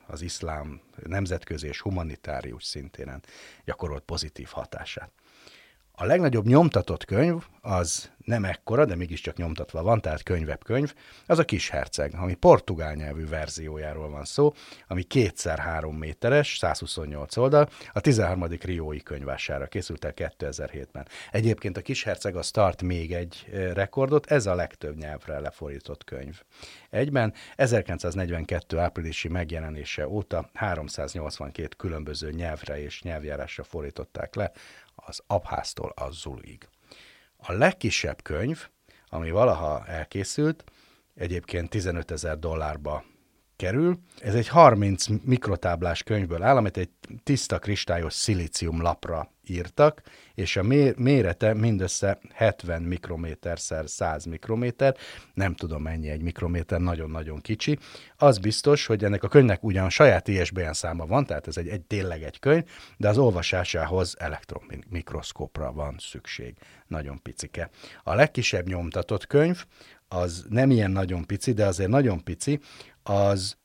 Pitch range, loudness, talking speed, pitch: 80-110 Hz, -26 LUFS, 130 wpm, 90 Hz